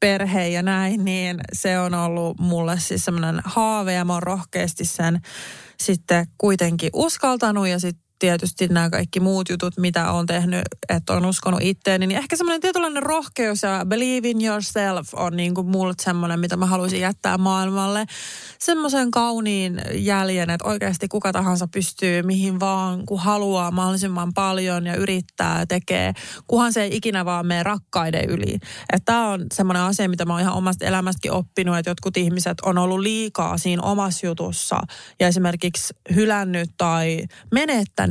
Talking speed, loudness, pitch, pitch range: 160 wpm, -21 LUFS, 185 Hz, 175-200 Hz